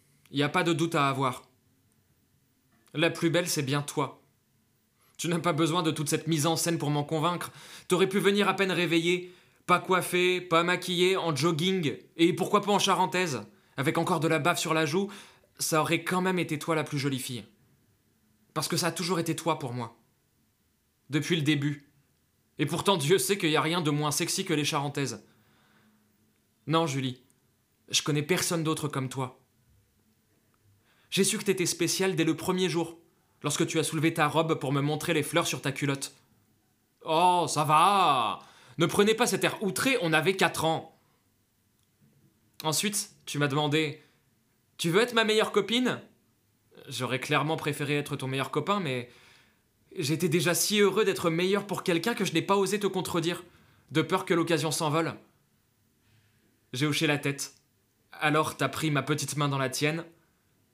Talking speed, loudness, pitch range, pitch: 180 wpm, -27 LUFS, 130-175 Hz, 155 Hz